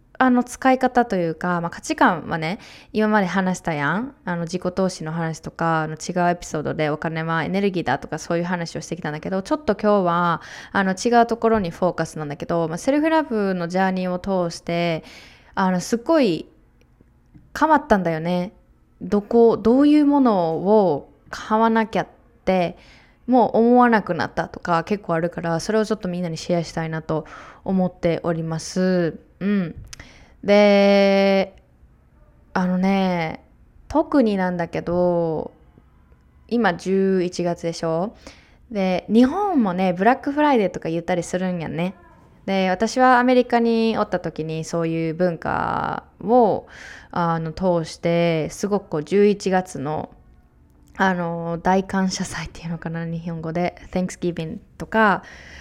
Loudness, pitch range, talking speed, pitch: -21 LUFS, 165-215 Hz, 310 characters per minute, 180 Hz